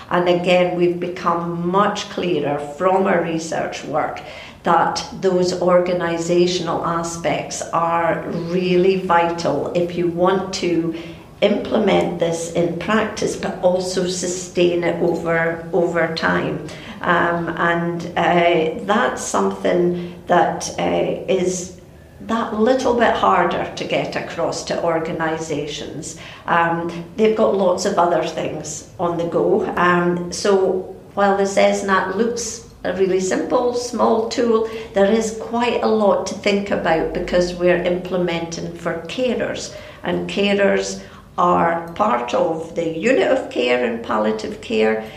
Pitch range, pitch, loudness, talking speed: 170-190 Hz, 175 Hz, -19 LUFS, 125 wpm